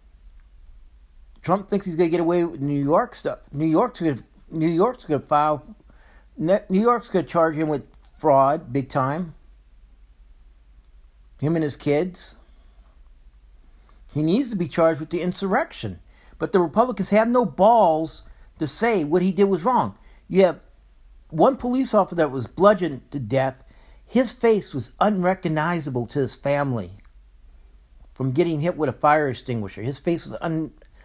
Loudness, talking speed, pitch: -22 LUFS, 155 wpm, 150 Hz